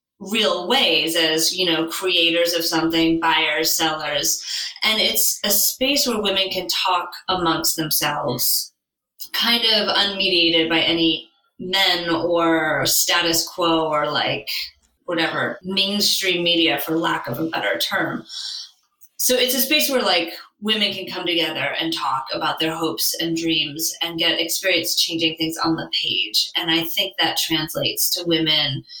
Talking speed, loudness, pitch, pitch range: 150 wpm, -19 LUFS, 170 Hz, 160-190 Hz